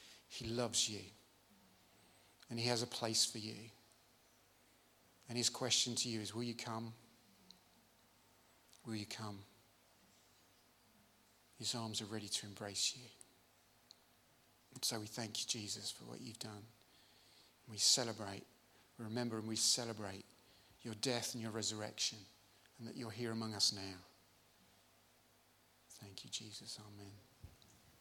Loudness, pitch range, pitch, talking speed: -40 LUFS, 105-115 Hz, 110 Hz, 130 wpm